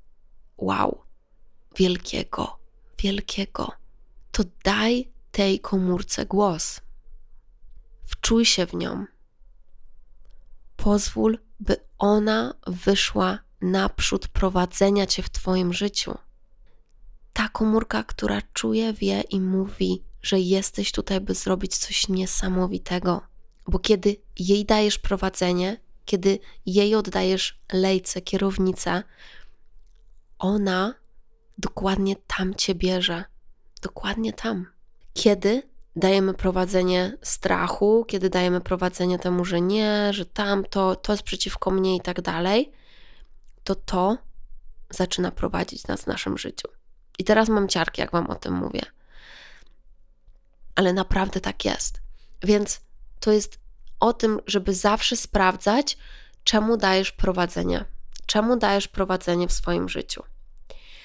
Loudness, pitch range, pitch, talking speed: -24 LUFS, 180-205 Hz, 190 Hz, 110 wpm